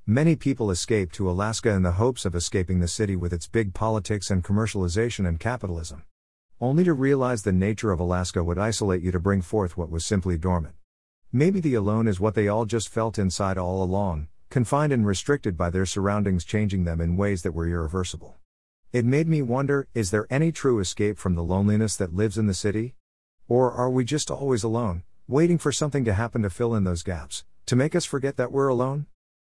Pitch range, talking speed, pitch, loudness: 90-120 Hz, 210 wpm, 105 Hz, -25 LUFS